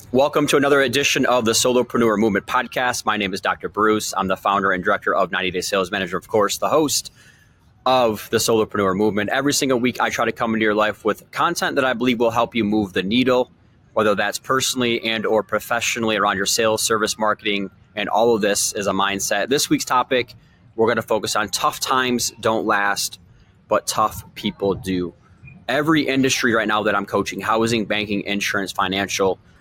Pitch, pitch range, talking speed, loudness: 110 Hz, 100-125 Hz, 200 wpm, -20 LUFS